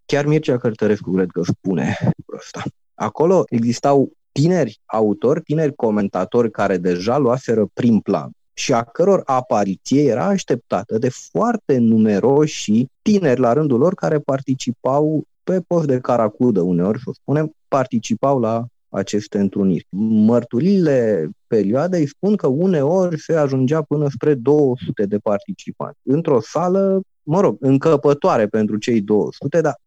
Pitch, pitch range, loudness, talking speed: 135 Hz, 115-155 Hz, -18 LUFS, 135 wpm